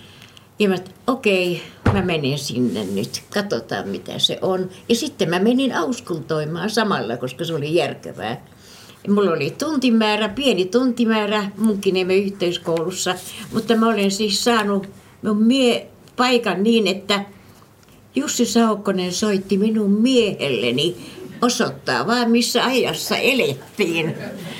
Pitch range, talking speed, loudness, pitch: 185-230 Hz, 125 wpm, -20 LUFS, 205 Hz